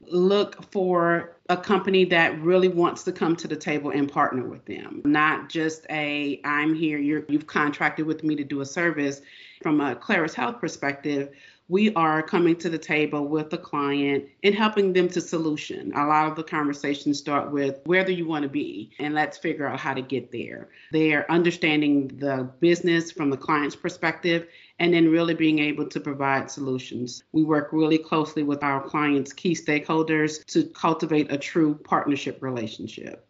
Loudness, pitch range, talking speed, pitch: -24 LUFS, 145-170 Hz, 185 wpm, 155 Hz